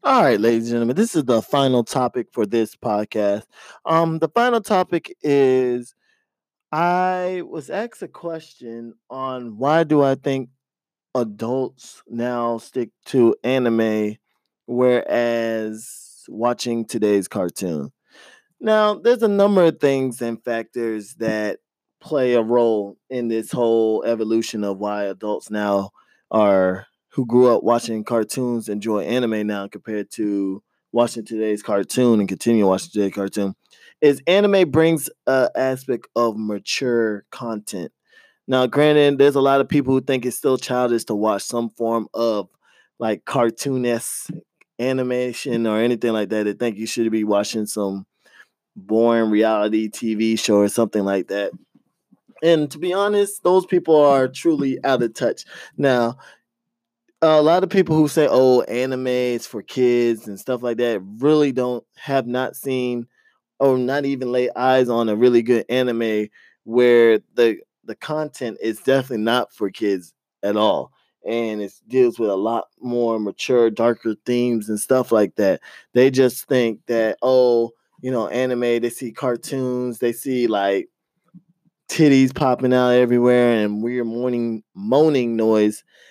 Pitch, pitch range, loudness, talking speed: 120 Hz, 110-135 Hz, -20 LUFS, 150 wpm